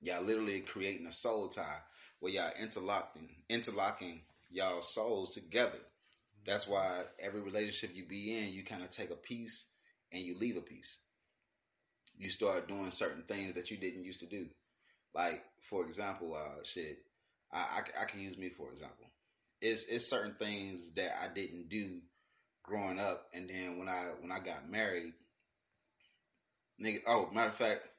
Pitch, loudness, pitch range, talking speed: 95 Hz, -38 LUFS, 90-105 Hz, 165 wpm